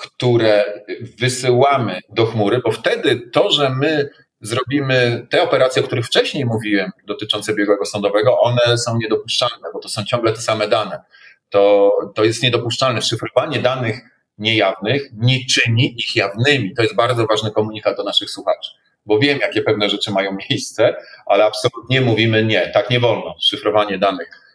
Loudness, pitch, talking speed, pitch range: -17 LUFS, 110 Hz, 155 wpm, 105-125 Hz